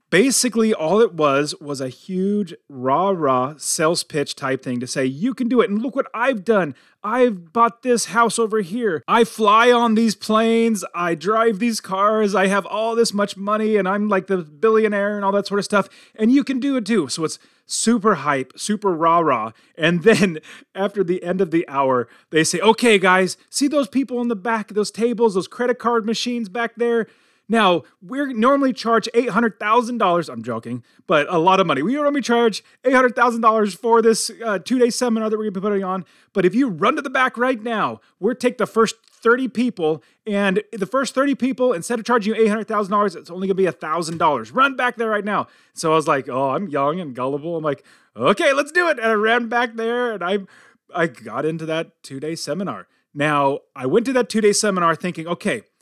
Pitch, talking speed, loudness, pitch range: 215 Hz, 215 wpm, -19 LUFS, 175-235 Hz